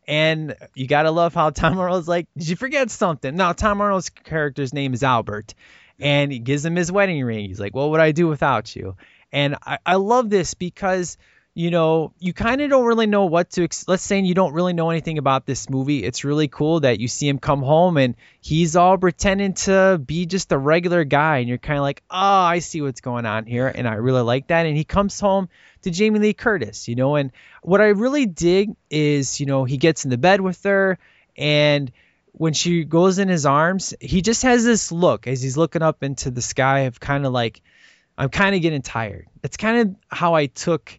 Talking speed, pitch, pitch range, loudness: 225 wpm, 160 Hz, 135-185 Hz, -19 LUFS